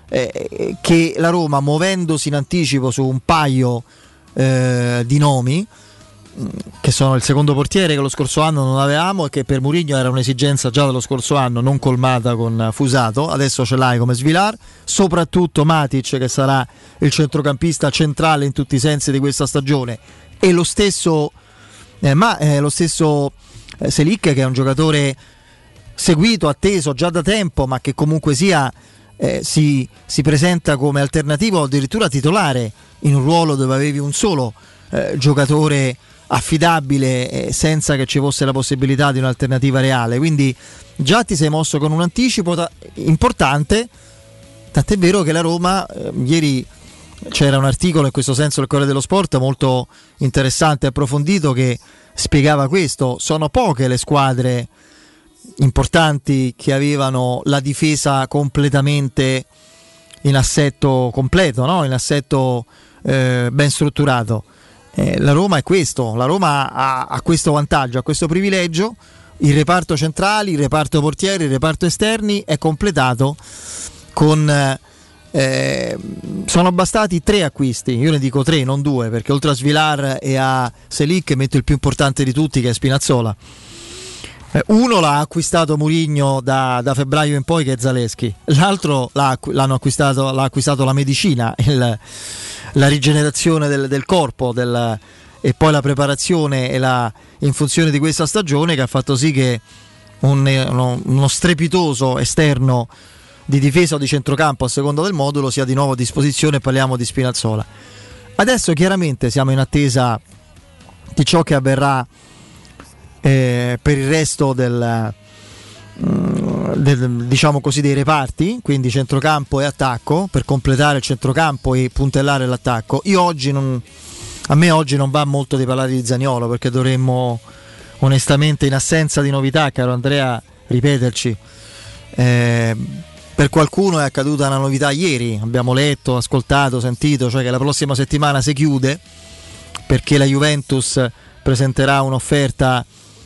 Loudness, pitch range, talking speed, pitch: -16 LUFS, 130-155 Hz, 150 wpm, 140 Hz